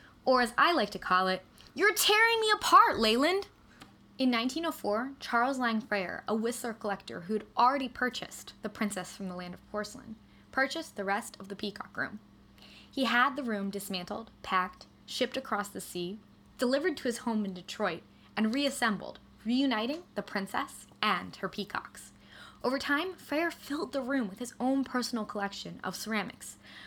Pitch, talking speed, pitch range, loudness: 230 Hz, 165 wpm, 205-270 Hz, -31 LUFS